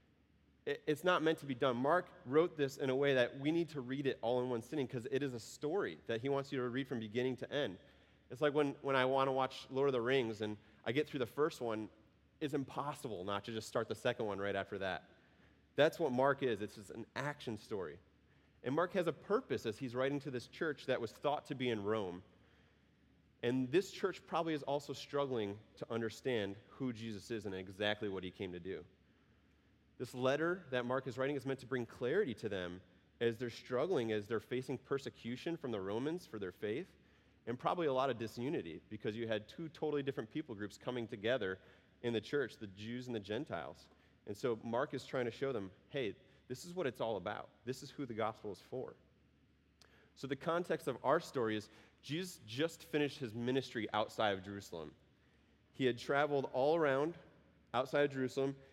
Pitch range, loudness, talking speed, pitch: 110-140 Hz, -39 LUFS, 215 wpm, 125 Hz